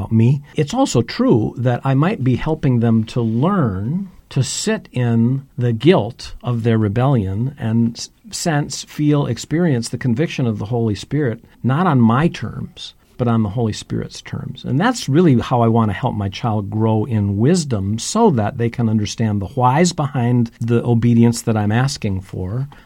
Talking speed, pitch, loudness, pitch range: 175 wpm, 120 Hz, -18 LUFS, 115-145 Hz